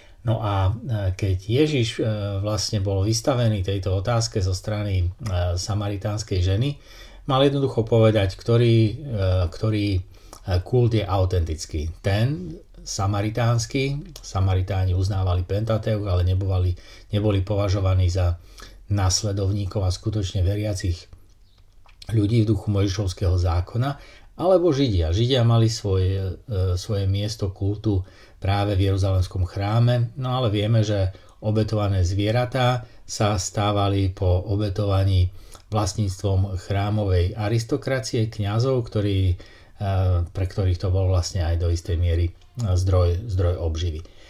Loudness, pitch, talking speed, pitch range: -23 LUFS, 100 Hz, 105 wpm, 95-110 Hz